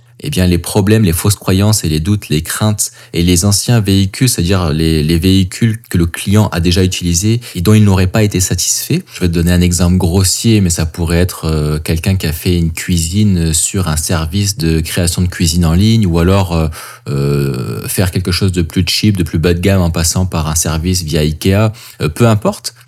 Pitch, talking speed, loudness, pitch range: 90 Hz, 225 wpm, -13 LUFS, 85-105 Hz